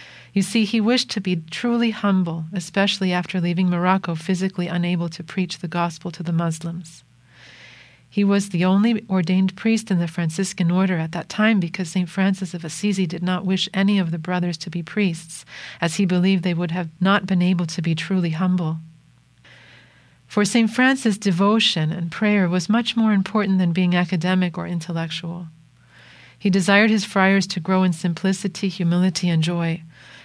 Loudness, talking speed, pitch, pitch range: -21 LUFS, 175 wpm, 185 Hz, 170-195 Hz